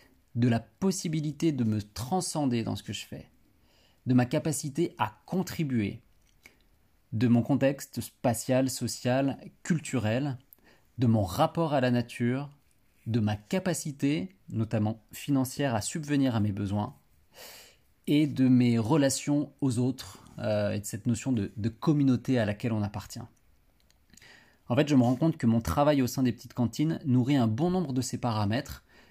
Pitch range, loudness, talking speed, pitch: 110-140 Hz, -29 LUFS, 160 wpm, 125 Hz